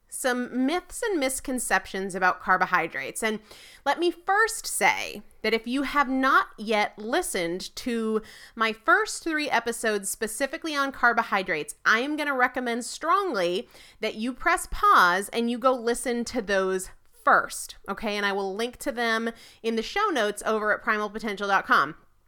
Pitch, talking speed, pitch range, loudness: 235 Hz, 155 wpm, 210-280 Hz, -25 LUFS